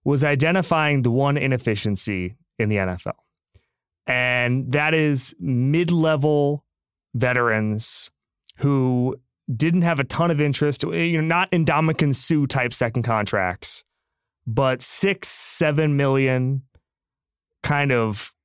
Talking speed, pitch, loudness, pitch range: 115 wpm, 135 Hz, -21 LUFS, 120-155 Hz